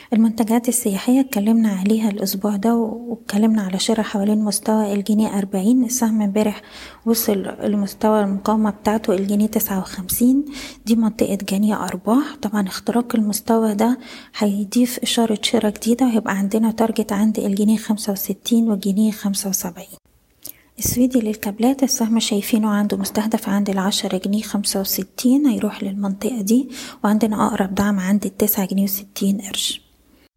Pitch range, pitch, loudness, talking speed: 205-230 Hz, 215 Hz, -19 LUFS, 130 wpm